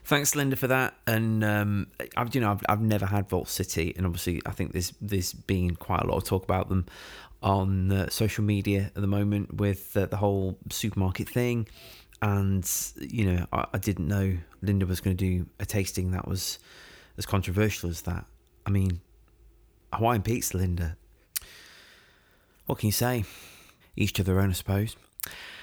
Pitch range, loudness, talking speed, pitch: 90-105 Hz, -28 LUFS, 180 wpm, 100 Hz